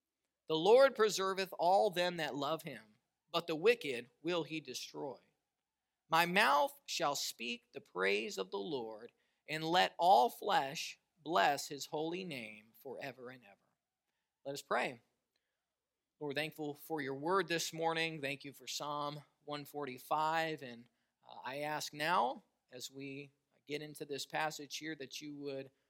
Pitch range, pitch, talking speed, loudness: 140-165 Hz, 150 Hz, 150 wpm, -36 LUFS